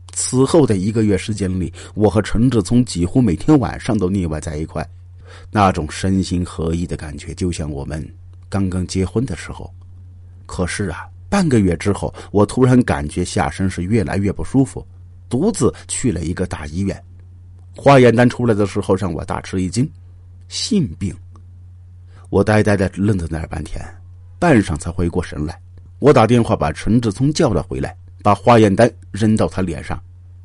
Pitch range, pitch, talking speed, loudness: 90-105 Hz, 90 Hz, 260 characters per minute, -17 LUFS